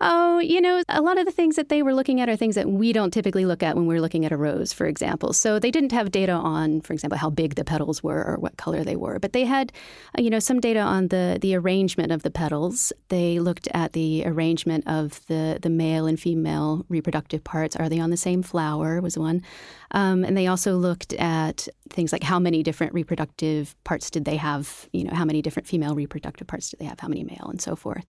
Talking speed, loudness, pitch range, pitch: 245 wpm, -24 LUFS, 160-200 Hz, 170 Hz